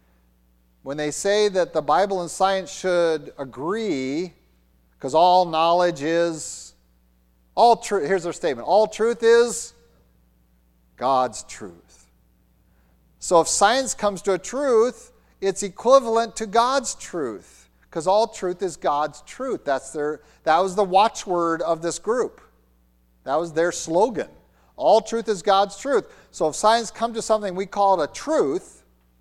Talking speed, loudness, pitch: 145 wpm, -22 LUFS, 170 Hz